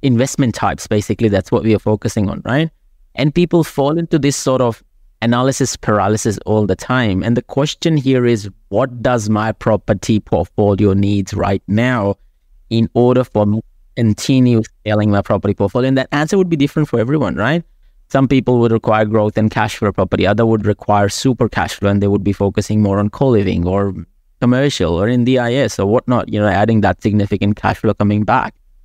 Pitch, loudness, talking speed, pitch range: 110 Hz, -15 LUFS, 195 wpm, 100-125 Hz